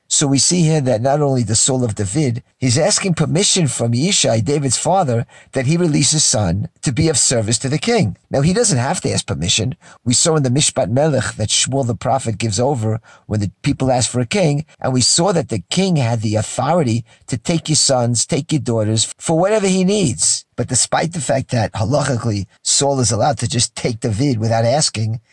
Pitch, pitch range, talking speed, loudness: 130 Hz, 115-155 Hz, 215 wpm, -16 LUFS